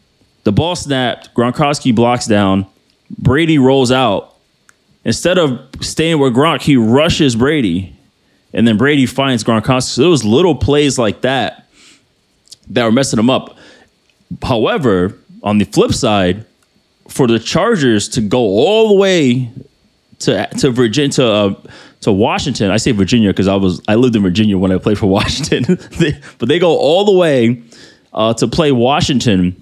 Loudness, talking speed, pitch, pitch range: -13 LUFS, 160 wpm, 120 Hz, 105-140 Hz